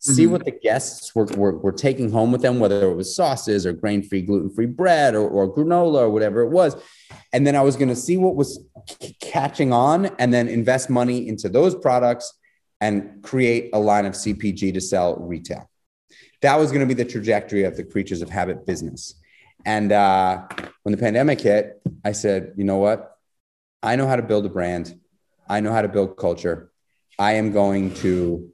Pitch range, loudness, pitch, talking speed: 100-125 Hz, -20 LUFS, 110 Hz, 205 wpm